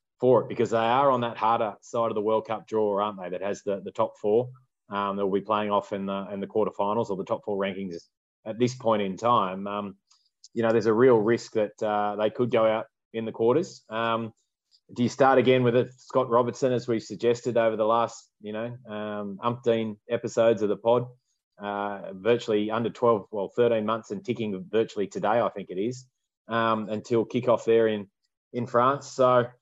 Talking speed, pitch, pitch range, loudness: 210 wpm, 115 Hz, 105-120 Hz, -26 LUFS